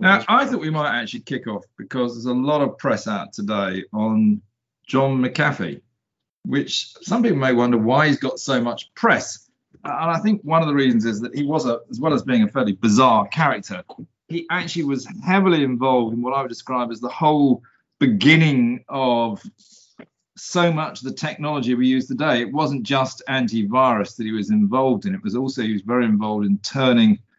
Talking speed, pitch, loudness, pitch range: 200 wpm, 130 Hz, -20 LUFS, 120-160 Hz